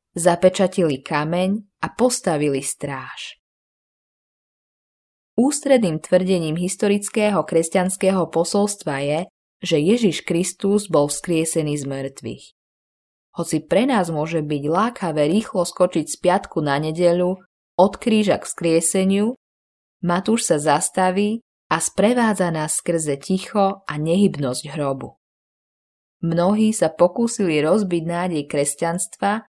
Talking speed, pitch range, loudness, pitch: 105 wpm, 155-200 Hz, -20 LUFS, 180 Hz